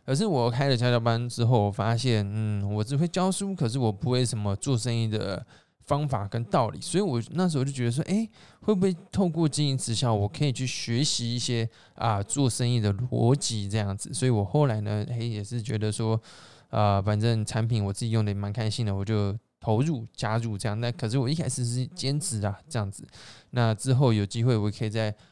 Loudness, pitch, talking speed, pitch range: -27 LUFS, 120 Hz, 320 characters per minute, 110-135 Hz